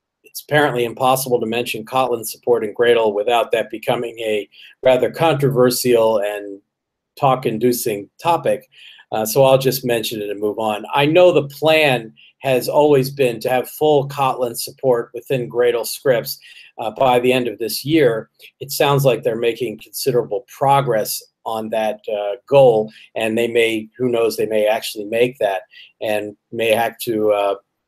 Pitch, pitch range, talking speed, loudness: 125 Hz, 110-150 Hz, 165 wpm, -18 LUFS